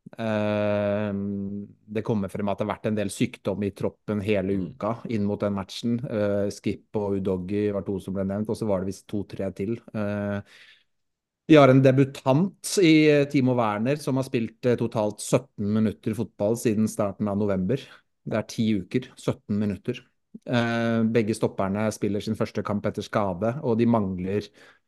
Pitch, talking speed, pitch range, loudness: 105 Hz, 165 wpm, 100-115 Hz, -25 LUFS